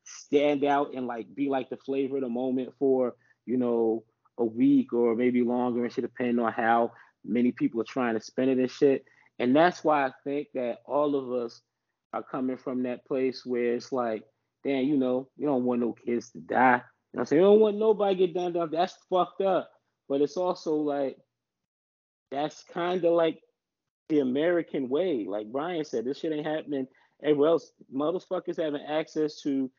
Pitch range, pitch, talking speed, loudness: 120-150 Hz, 135 Hz, 200 wpm, -28 LUFS